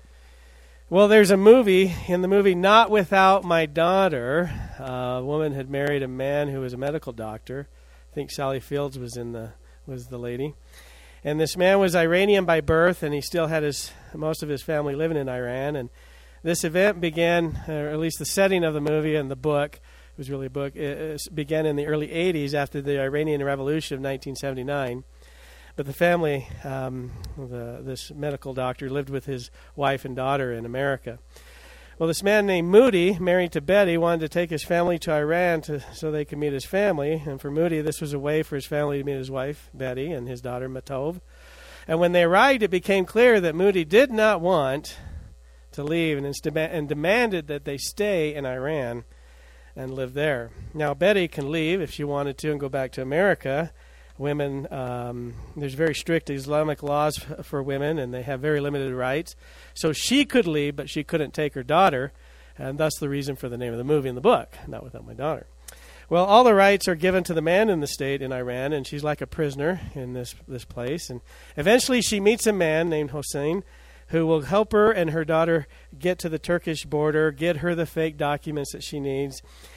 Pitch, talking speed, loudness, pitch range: 150 Hz, 205 wpm, -23 LUFS, 130-165 Hz